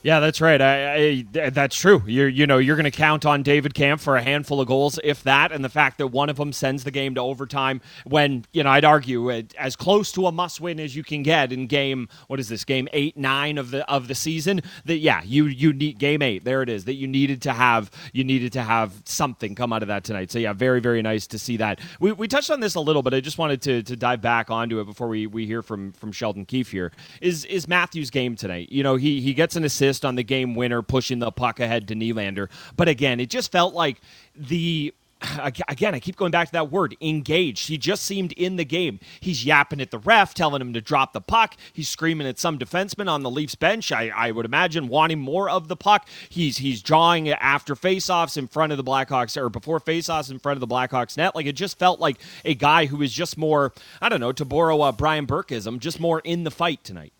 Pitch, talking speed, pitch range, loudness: 145 Hz, 255 wpm, 125-160 Hz, -22 LUFS